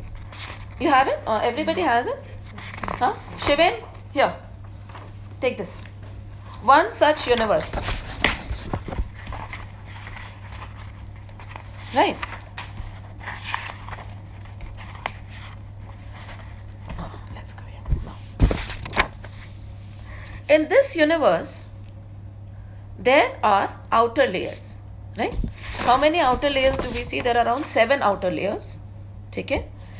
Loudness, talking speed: -22 LUFS, 85 wpm